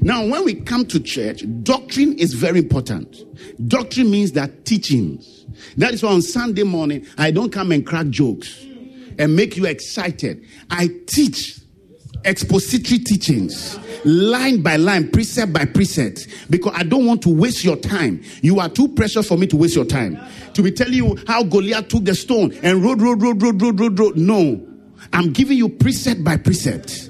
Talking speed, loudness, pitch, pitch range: 180 wpm, -17 LUFS, 195 Hz, 165-235 Hz